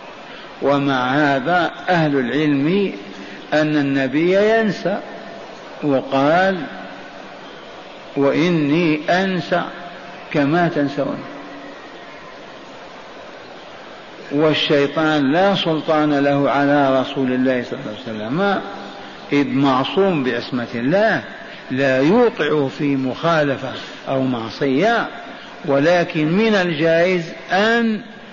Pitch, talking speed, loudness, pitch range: 150 Hz, 80 wpm, -18 LUFS, 140-175 Hz